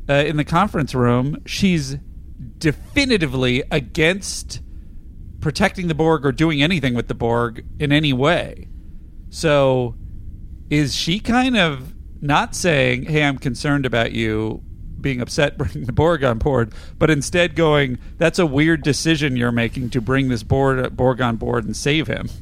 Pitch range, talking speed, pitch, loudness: 120-155 Hz, 155 wpm, 140 Hz, -19 LUFS